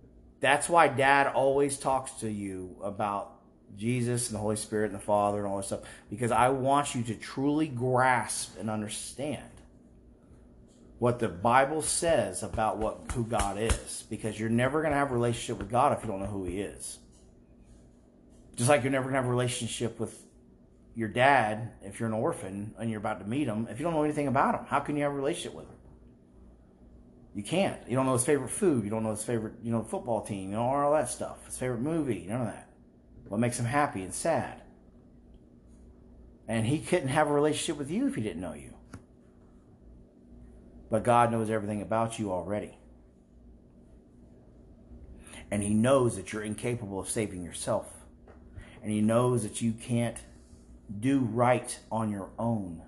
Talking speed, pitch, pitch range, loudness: 190 wpm, 110 Hz, 90-125 Hz, -29 LUFS